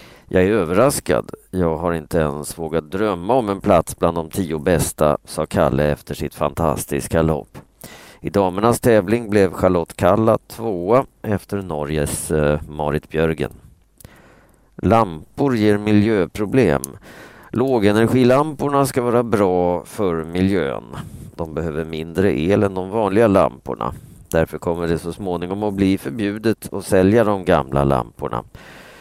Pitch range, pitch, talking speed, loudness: 80-105 Hz, 95 Hz, 130 wpm, -19 LUFS